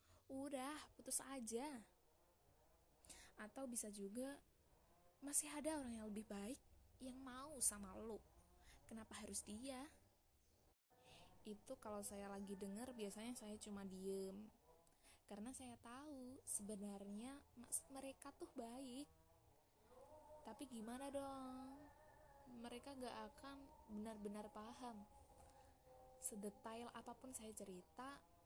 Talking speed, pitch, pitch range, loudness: 100 wpm, 240 Hz, 210-270 Hz, -52 LUFS